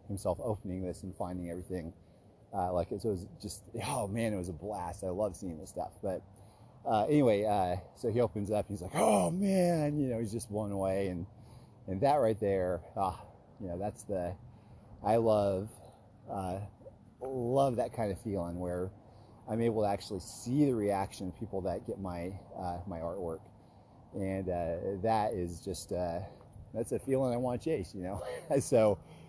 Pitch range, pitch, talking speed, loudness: 90-115 Hz, 100 Hz, 190 wpm, -34 LUFS